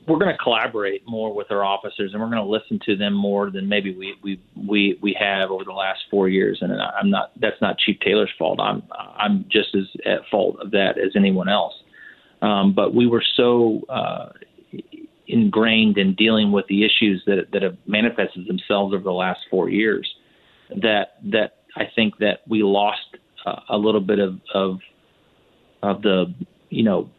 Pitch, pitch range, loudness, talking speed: 100 Hz, 95-110 Hz, -20 LUFS, 190 wpm